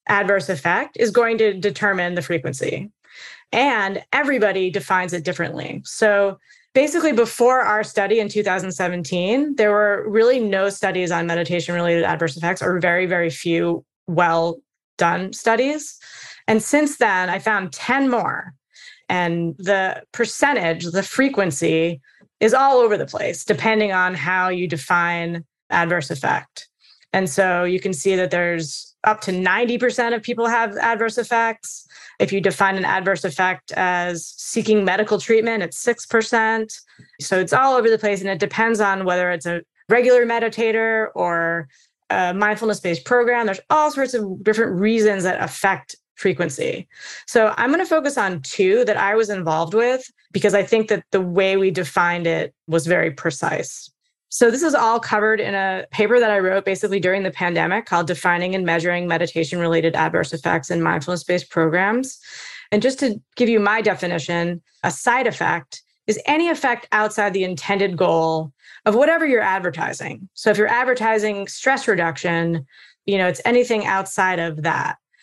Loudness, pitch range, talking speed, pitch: -19 LUFS, 175-230 Hz, 160 wpm, 195 Hz